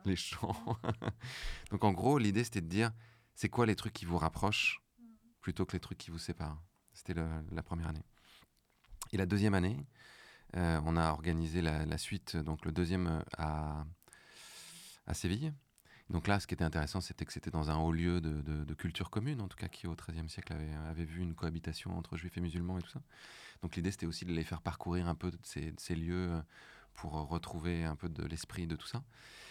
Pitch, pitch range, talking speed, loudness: 85 Hz, 80-95 Hz, 215 wpm, -38 LUFS